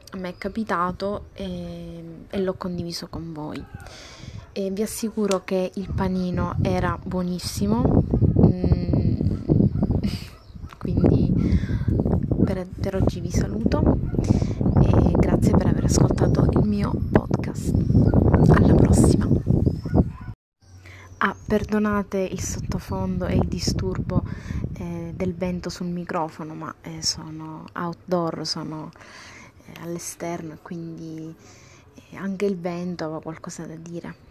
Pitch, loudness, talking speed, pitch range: 170 Hz, -23 LUFS, 100 wpm, 155-185 Hz